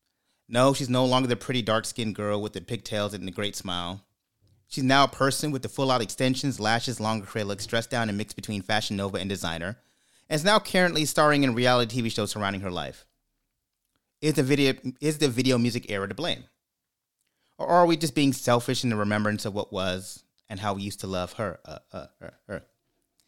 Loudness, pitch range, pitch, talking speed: -26 LUFS, 100-130 Hz, 115 Hz, 210 wpm